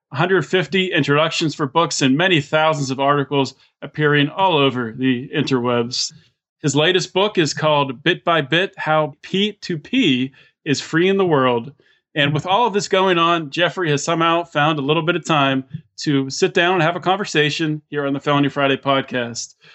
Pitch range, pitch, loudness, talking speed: 140-175 Hz, 155 Hz, -18 LUFS, 175 wpm